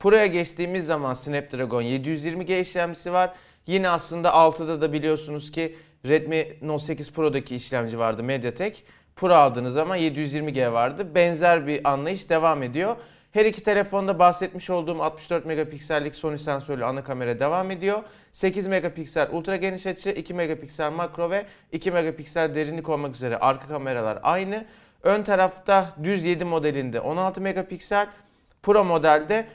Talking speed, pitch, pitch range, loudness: 140 wpm, 165 Hz, 150-185 Hz, -24 LUFS